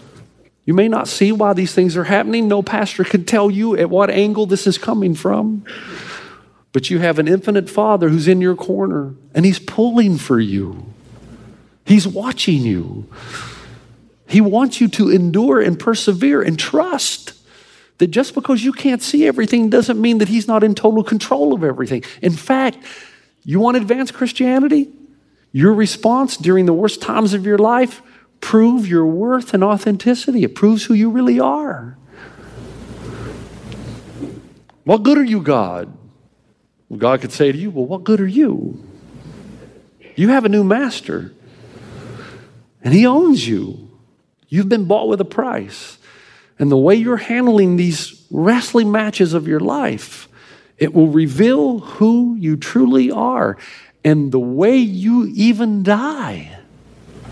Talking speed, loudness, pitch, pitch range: 155 wpm, -15 LUFS, 205 Hz, 170-230 Hz